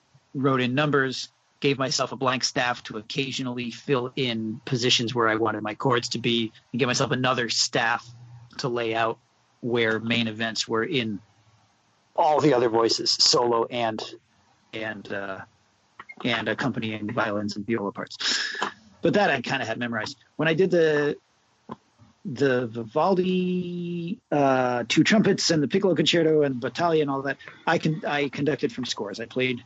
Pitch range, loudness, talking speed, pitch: 115-145 Hz, -24 LUFS, 165 wpm, 125 Hz